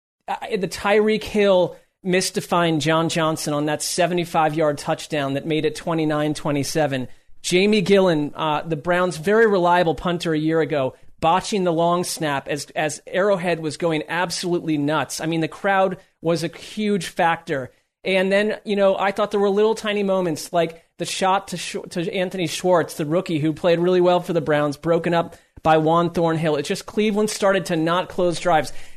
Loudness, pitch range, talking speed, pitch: -21 LUFS, 155-190 Hz, 180 wpm, 170 Hz